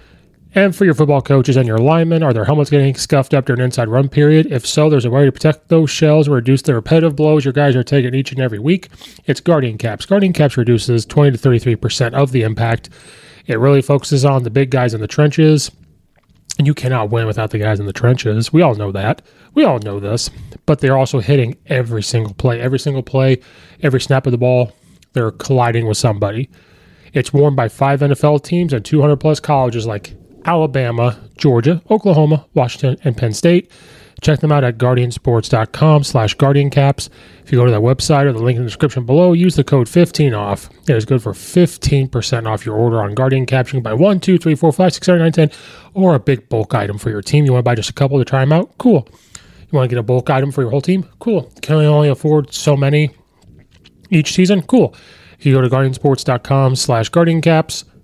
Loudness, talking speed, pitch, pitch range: -14 LUFS, 220 wpm, 135 Hz, 120-150 Hz